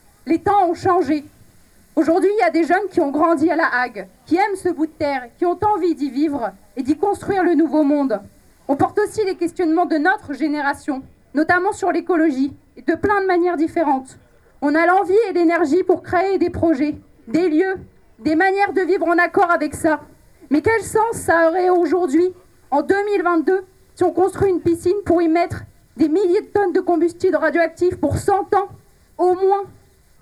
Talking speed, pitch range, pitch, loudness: 195 wpm, 315-375 Hz, 345 Hz, -18 LUFS